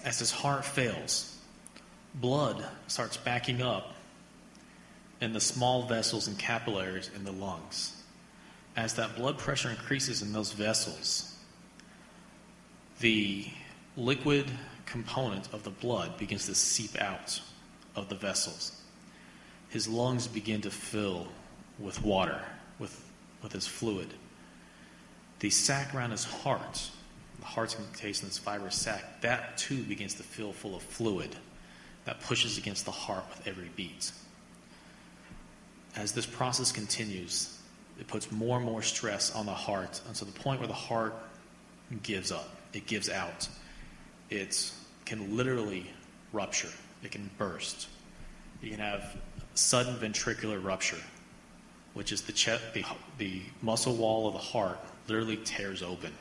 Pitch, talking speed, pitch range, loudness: 110 Hz, 135 wpm, 100-120 Hz, -33 LUFS